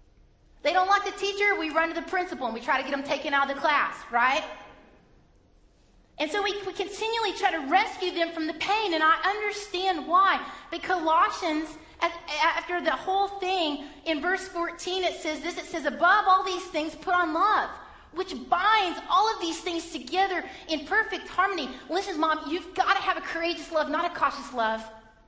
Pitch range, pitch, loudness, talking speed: 315-380 Hz, 345 Hz, -26 LUFS, 195 wpm